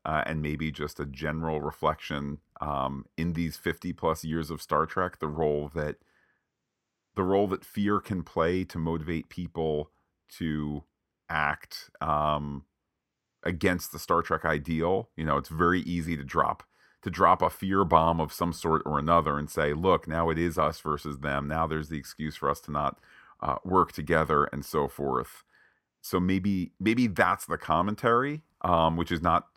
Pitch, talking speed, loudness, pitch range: 80 Hz, 175 wpm, -29 LUFS, 75-85 Hz